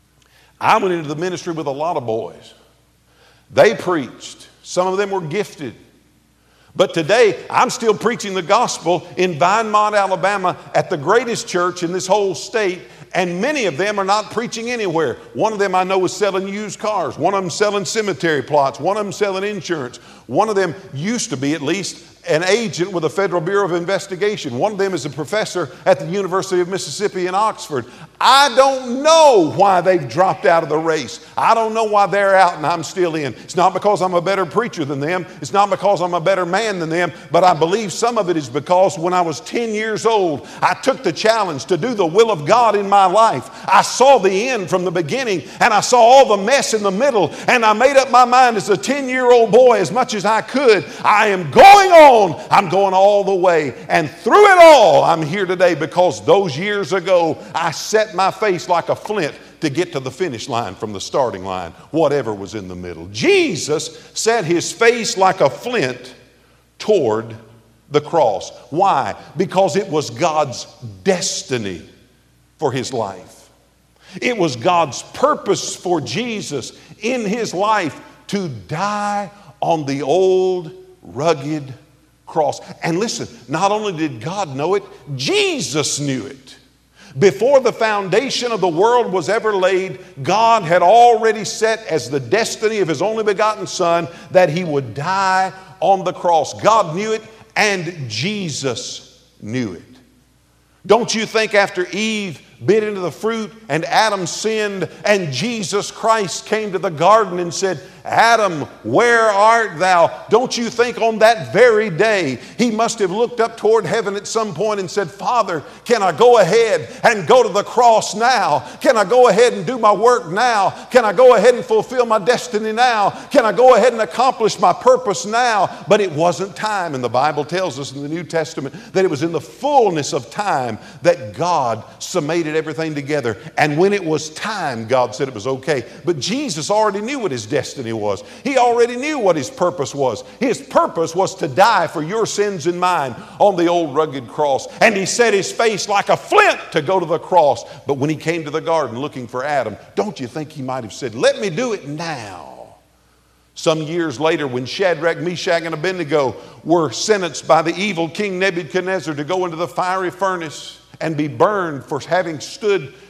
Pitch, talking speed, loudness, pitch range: 185 Hz, 190 wpm, -16 LUFS, 160-215 Hz